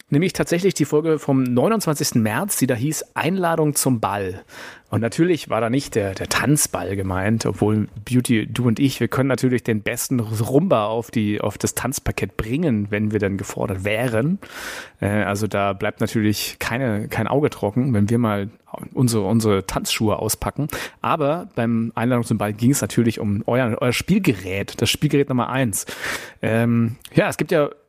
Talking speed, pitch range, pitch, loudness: 170 wpm, 105-135 Hz, 115 Hz, -21 LUFS